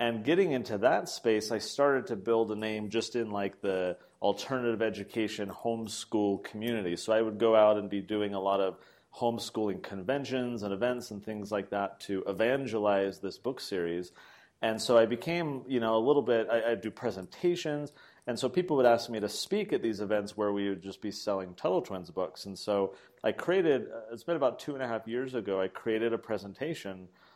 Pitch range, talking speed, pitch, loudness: 100-120 Hz, 205 wpm, 110 Hz, -31 LUFS